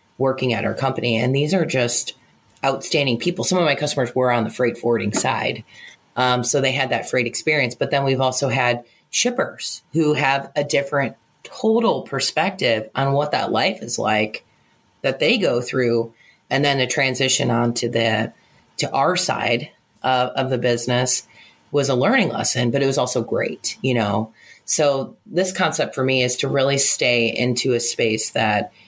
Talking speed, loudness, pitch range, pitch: 180 wpm, -20 LUFS, 120-140 Hz, 130 Hz